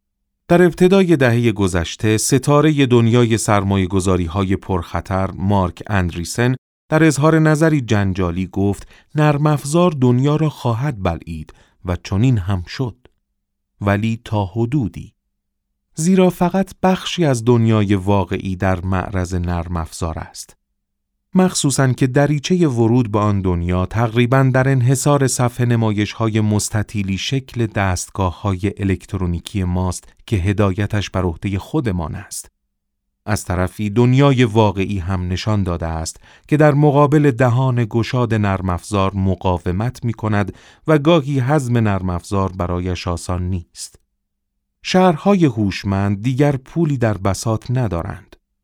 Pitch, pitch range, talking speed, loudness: 105 Hz, 95-130 Hz, 115 wpm, -17 LUFS